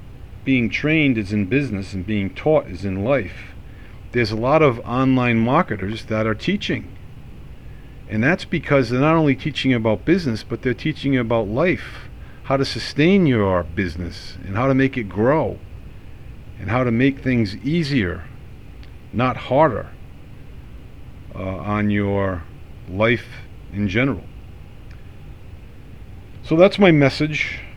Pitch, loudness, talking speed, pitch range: 115 Hz, -20 LUFS, 135 wpm, 100-130 Hz